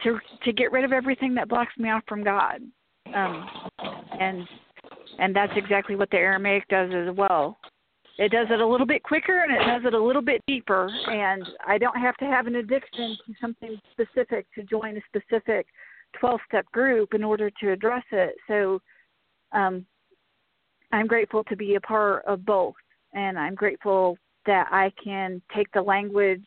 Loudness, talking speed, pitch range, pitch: -25 LUFS, 180 wpm, 195-240 Hz, 215 Hz